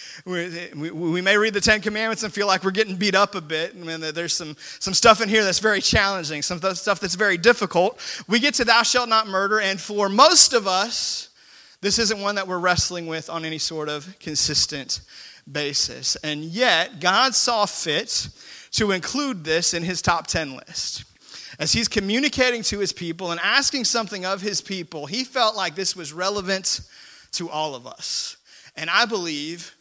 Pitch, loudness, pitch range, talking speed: 195 Hz, -21 LUFS, 170-220 Hz, 190 wpm